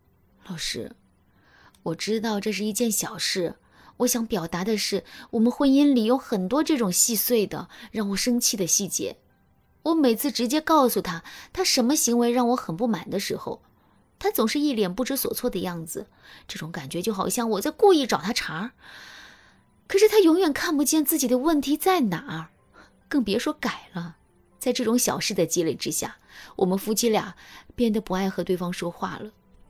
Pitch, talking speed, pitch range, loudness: 230 Hz, 265 characters per minute, 195-275 Hz, -24 LUFS